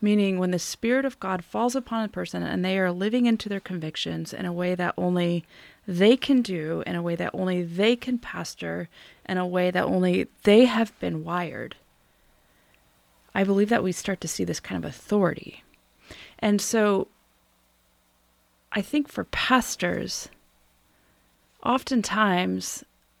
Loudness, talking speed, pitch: -25 LUFS, 155 wpm, 180 Hz